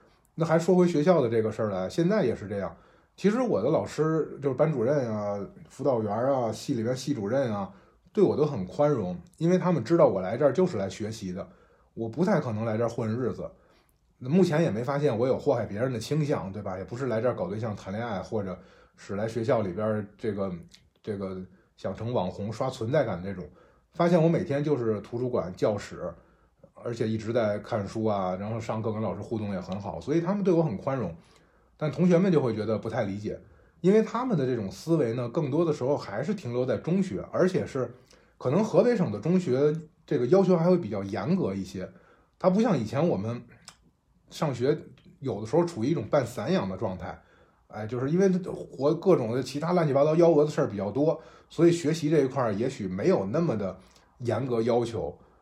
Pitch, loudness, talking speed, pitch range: 130 Hz, -27 LUFS, 315 characters per minute, 110-165 Hz